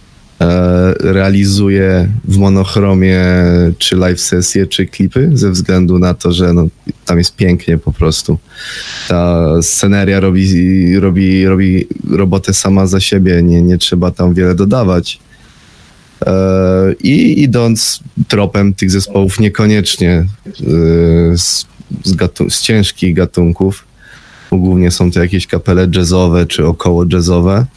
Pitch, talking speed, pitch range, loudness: 90 Hz, 120 wpm, 90-95 Hz, -10 LUFS